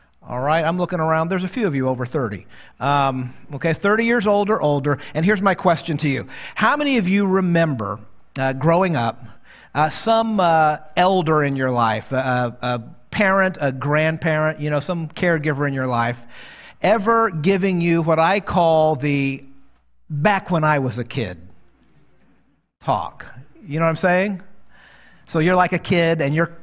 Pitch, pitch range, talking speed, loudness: 155 Hz, 135-180 Hz, 175 wpm, -19 LUFS